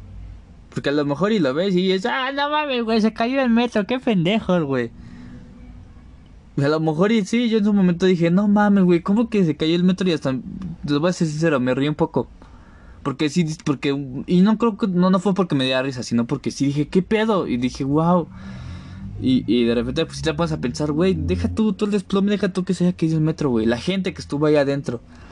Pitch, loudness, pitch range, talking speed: 160 Hz, -20 LUFS, 125-195 Hz, 245 wpm